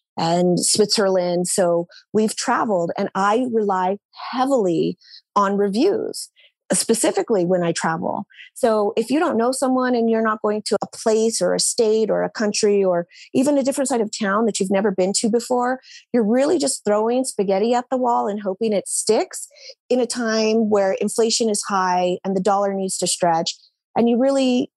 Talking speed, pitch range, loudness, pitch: 180 wpm, 195-245 Hz, -20 LUFS, 215 Hz